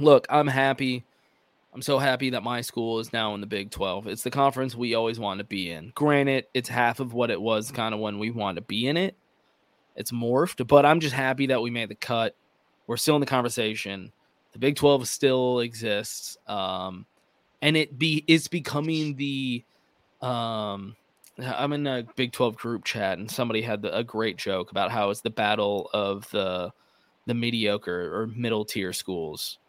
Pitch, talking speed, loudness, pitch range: 120 Hz, 195 wpm, -26 LUFS, 105-135 Hz